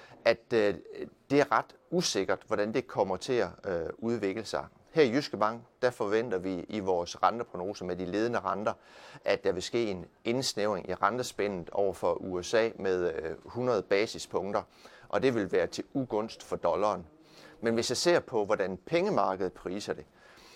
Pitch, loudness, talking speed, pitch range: 115 Hz, -31 LUFS, 165 wpm, 95-135 Hz